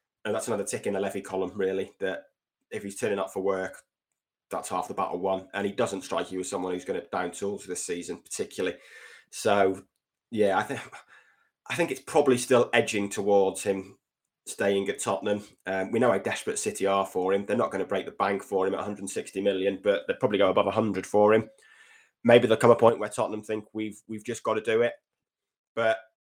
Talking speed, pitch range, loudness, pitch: 220 wpm, 95-110 Hz, -27 LUFS, 100 Hz